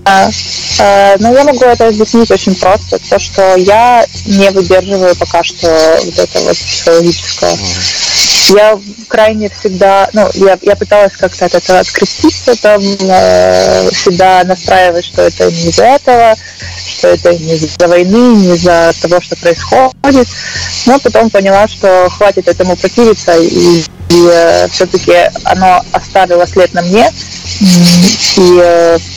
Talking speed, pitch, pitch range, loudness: 135 wpm, 185 Hz, 170-210 Hz, -7 LUFS